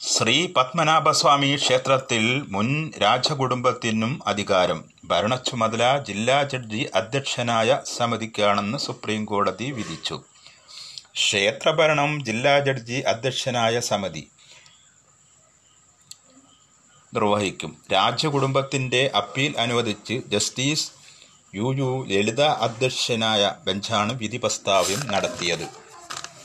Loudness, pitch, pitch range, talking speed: -22 LUFS, 125 Hz, 110-140 Hz, 75 wpm